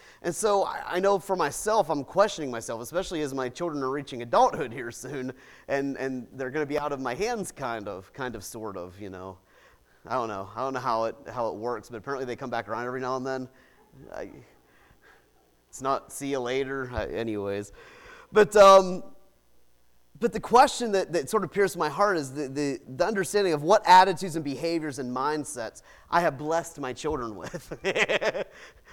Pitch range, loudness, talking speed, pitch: 120-185 Hz, -26 LUFS, 200 wpm, 140 Hz